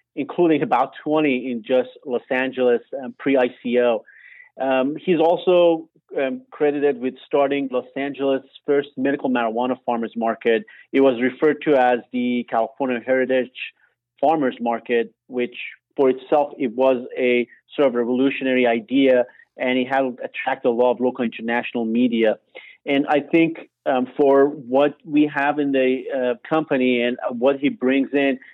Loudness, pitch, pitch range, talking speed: -21 LUFS, 130 Hz, 125-140 Hz, 150 wpm